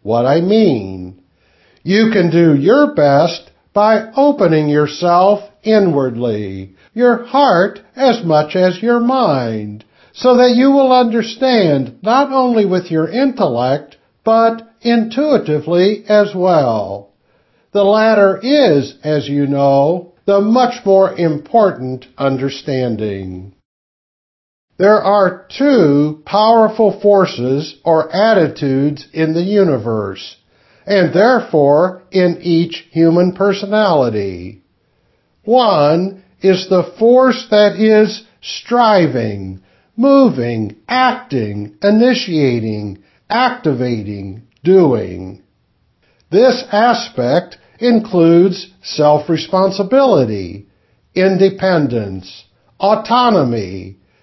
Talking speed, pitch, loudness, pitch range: 85 wpm, 180 Hz, -13 LUFS, 130-215 Hz